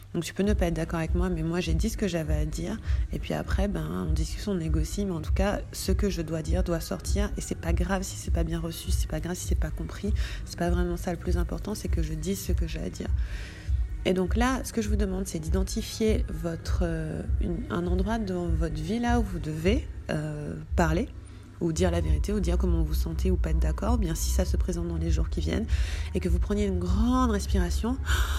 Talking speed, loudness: 275 wpm, -29 LUFS